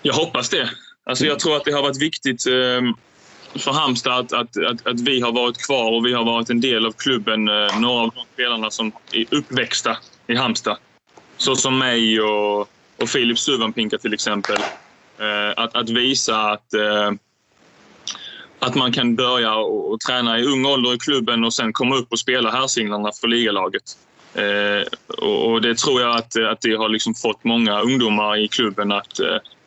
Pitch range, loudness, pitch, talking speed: 110-125 Hz, -19 LUFS, 115 Hz, 170 wpm